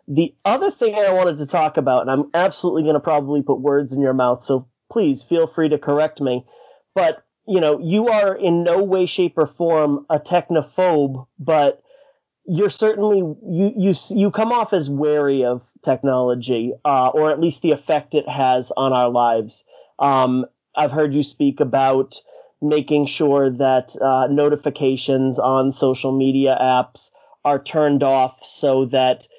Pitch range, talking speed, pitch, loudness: 135-170 Hz, 165 wpm, 145 Hz, -18 LUFS